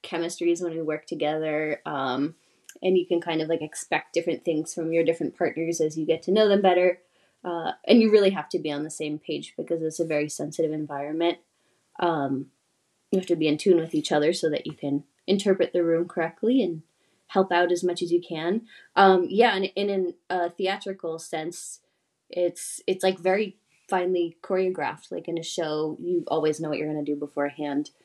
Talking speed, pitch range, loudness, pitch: 210 wpm, 155-185 Hz, -26 LUFS, 170 Hz